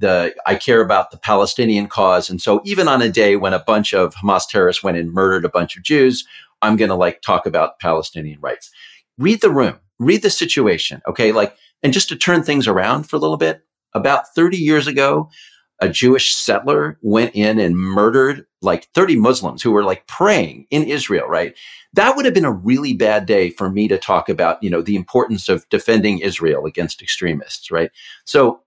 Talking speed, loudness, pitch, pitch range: 205 wpm, -16 LUFS, 105 Hz, 95-140 Hz